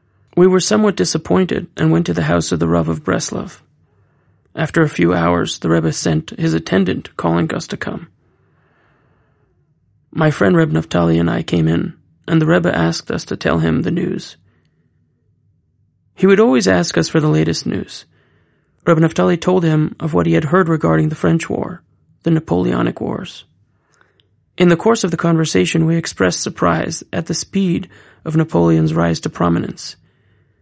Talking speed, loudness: 170 wpm, -16 LUFS